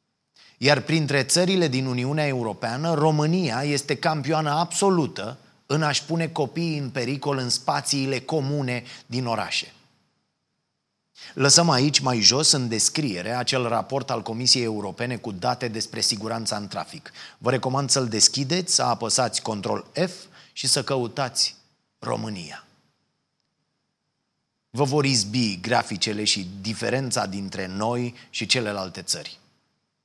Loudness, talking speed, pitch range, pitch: -23 LUFS, 120 wpm, 115-145 Hz, 130 Hz